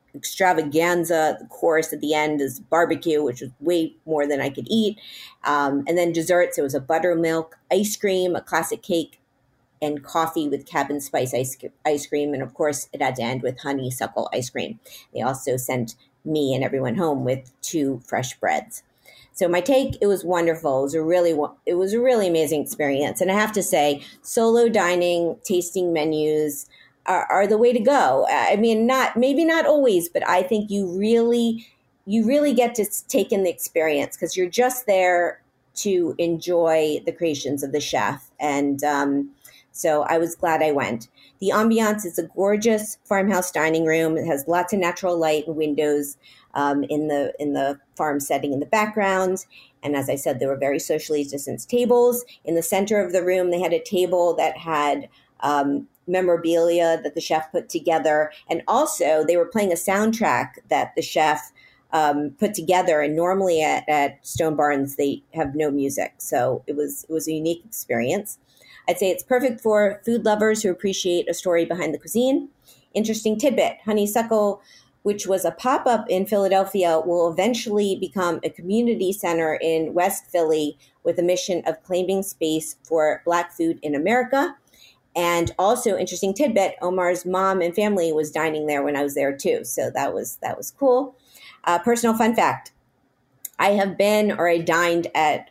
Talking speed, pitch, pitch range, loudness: 185 wpm, 170 Hz, 150-195 Hz, -22 LUFS